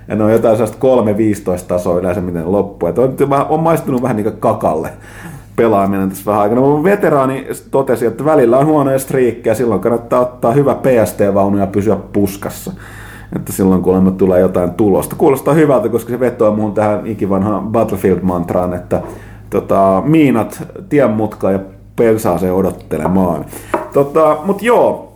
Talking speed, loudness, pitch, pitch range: 155 wpm, -13 LUFS, 105 Hz, 95-125 Hz